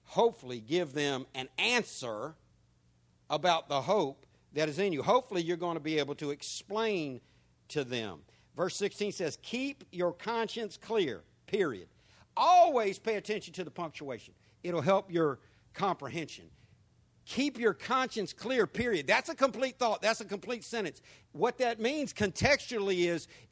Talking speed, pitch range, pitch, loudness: 150 wpm, 145-225 Hz, 175 Hz, -32 LUFS